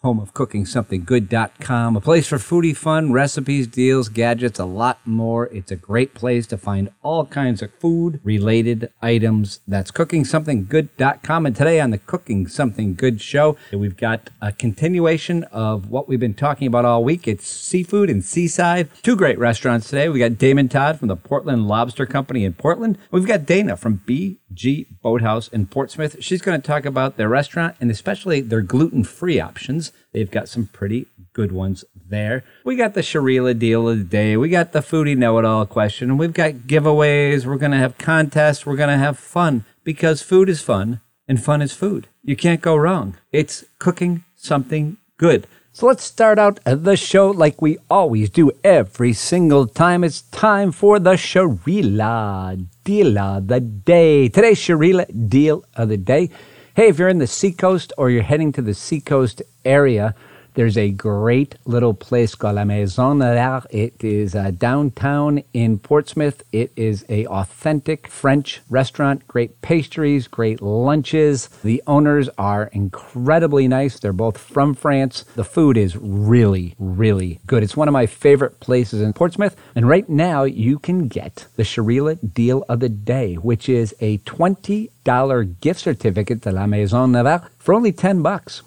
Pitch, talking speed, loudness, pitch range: 130 Hz, 175 wpm, -18 LUFS, 115-155 Hz